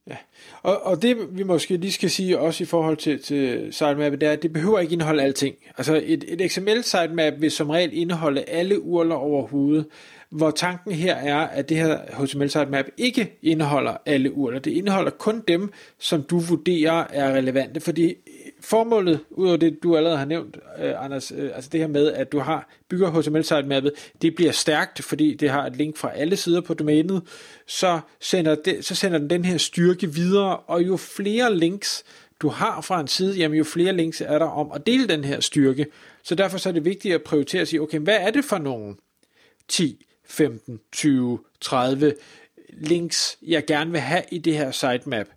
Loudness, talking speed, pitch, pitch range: -22 LUFS, 195 wpm, 160 Hz, 145-180 Hz